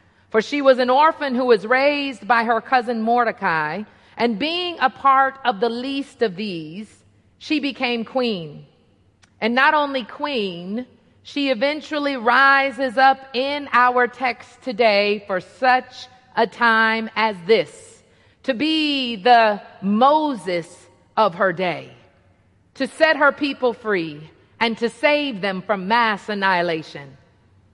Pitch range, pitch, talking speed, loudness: 205-270 Hz, 235 Hz, 130 wpm, -19 LUFS